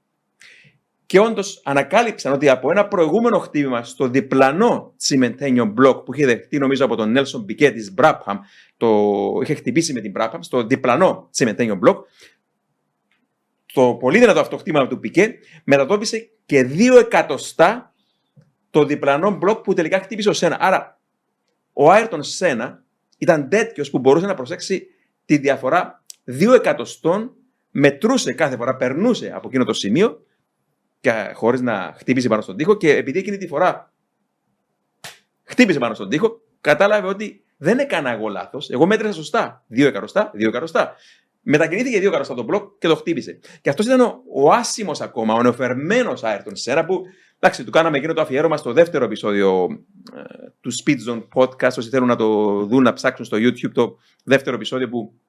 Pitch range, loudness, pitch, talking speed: 125-205 Hz, -18 LUFS, 150 Hz, 160 wpm